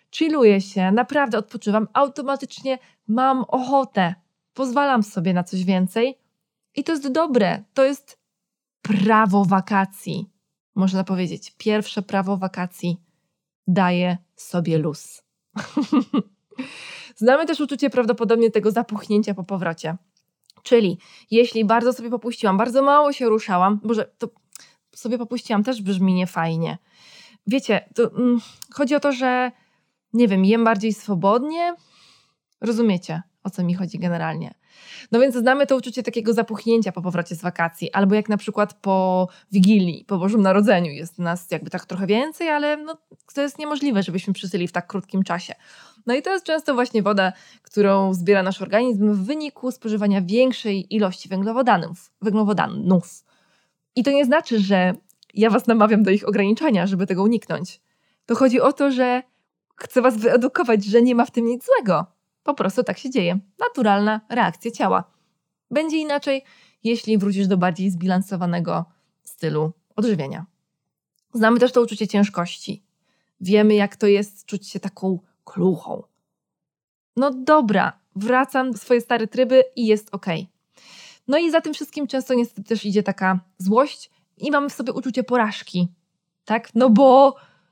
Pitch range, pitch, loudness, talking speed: 190-250 Hz, 210 Hz, -20 LUFS, 145 wpm